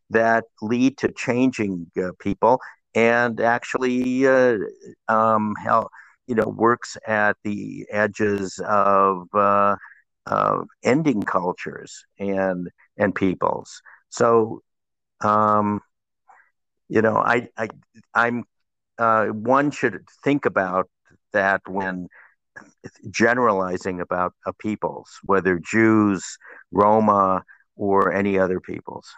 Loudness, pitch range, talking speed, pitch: -21 LUFS, 95-115 Hz, 105 wpm, 105 Hz